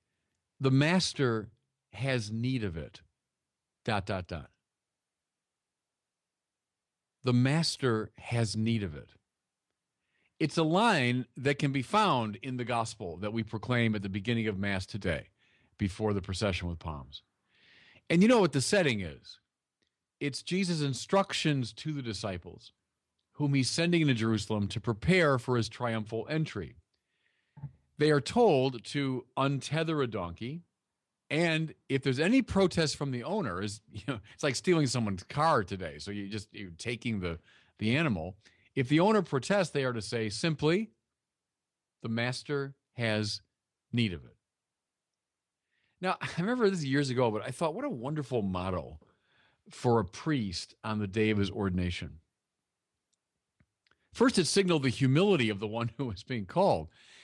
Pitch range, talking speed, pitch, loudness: 105-145 Hz, 150 wpm, 120 Hz, -30 LUFS